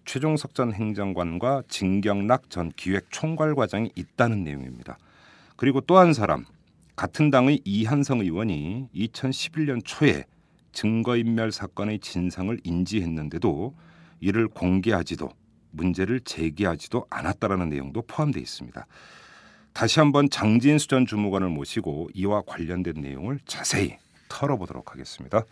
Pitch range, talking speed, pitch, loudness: 90-130 Hz, 305 characters per minute, 110 Hz, -25 LUFS